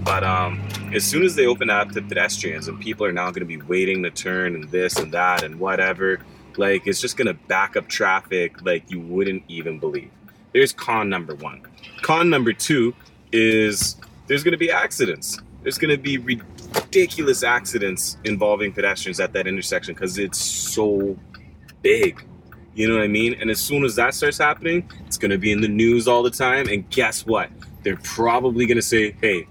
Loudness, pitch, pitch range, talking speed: -21 LUFS, 110 Hz, 100-125 Hz, 185 wpm